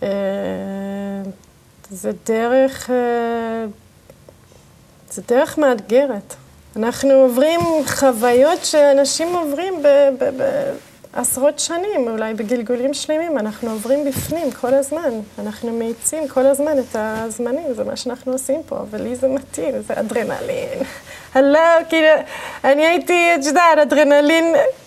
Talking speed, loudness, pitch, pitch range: 120 wpm, -17 LUFS, 275 Hz, 235-300 Hz